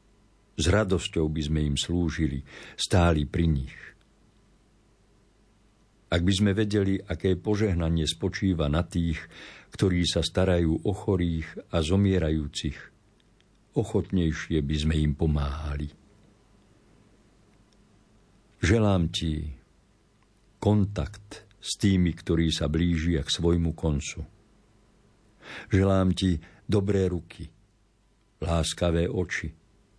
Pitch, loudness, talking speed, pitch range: 90 Hz, -27 LUFS, 95 wpm, 80-100 Hz